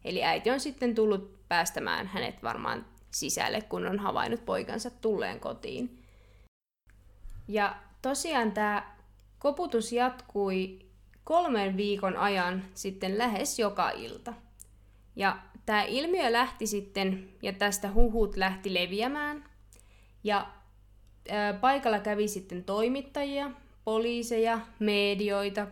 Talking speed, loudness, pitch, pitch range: 105 wpm, -30 LUFS, 205 Hz, 185-235 Hz